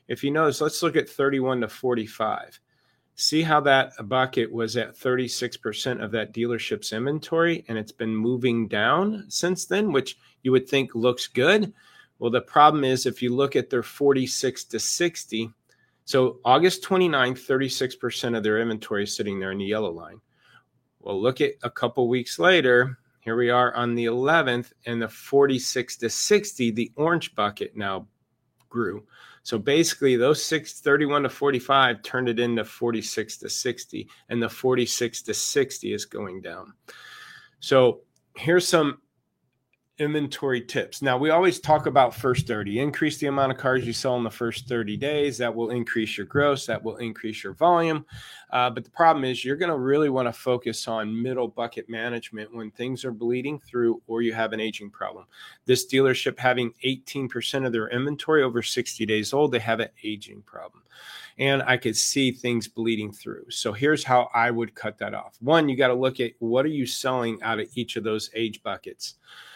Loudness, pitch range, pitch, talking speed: -24 LUFS, 115-140 Hz, 125 Hz, 185 wpm